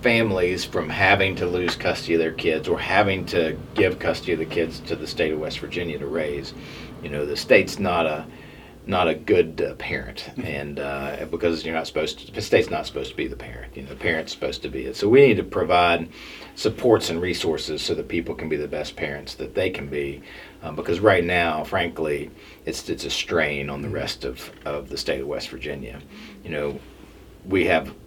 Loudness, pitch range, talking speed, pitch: -23 LUFS, 70-90 Hz, 220 wpm, 80 Hz